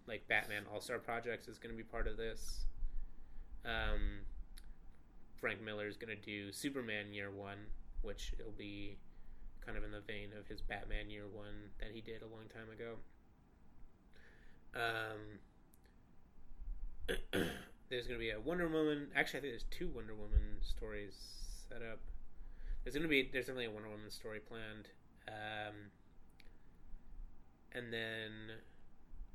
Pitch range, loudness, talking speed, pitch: 100-110 Hz, -44 LUFS, 150 wpm, 105 Hz